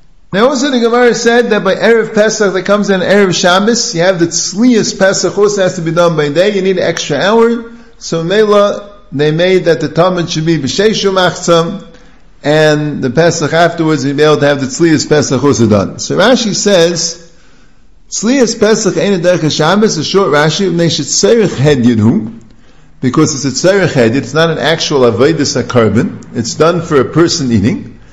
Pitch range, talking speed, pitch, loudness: 150-200 Hz, 175 wpm, 170 Hz, -10 LUFS